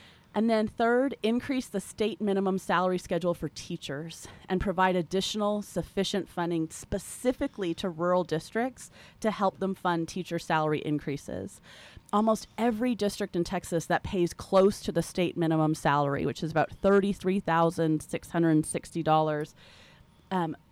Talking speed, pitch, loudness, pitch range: 130 wpm, 180 Hz, -29 LUFS, 165-205 Hz